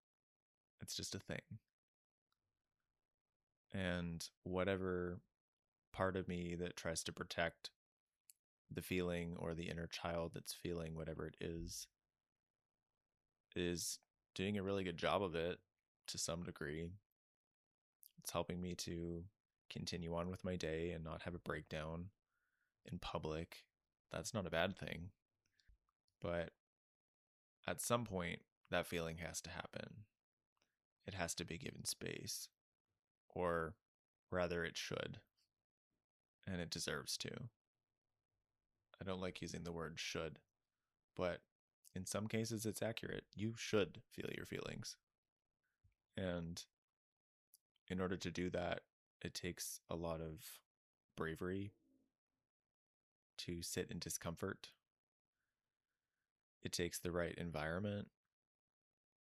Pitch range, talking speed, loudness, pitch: 85-95 Hz, 120 wpm, -46 LUFS, 90 Hz